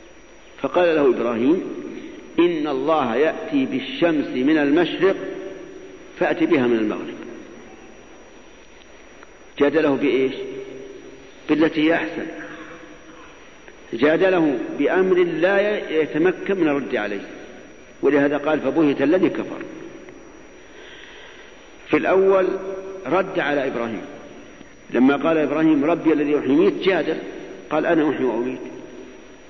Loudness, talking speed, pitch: -20 LUFS, 90 wpm, 195 Hz